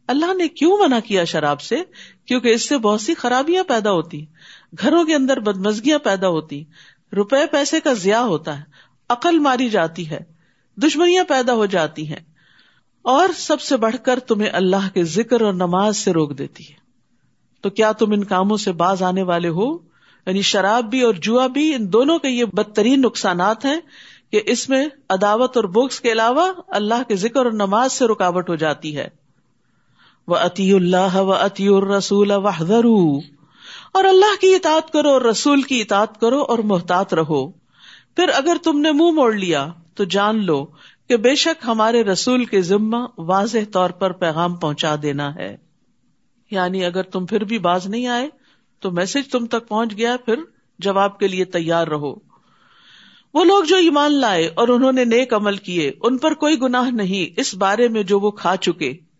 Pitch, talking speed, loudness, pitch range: 215 Hz, 180 wpm, -18 LUFS, 185-255 Hz